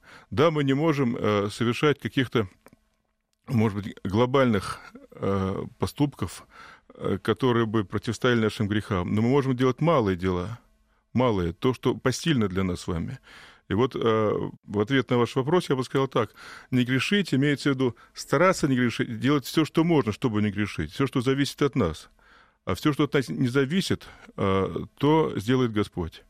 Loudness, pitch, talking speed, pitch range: -25 LUFS, 125 Hz, 170 wpm, 105-140 Hz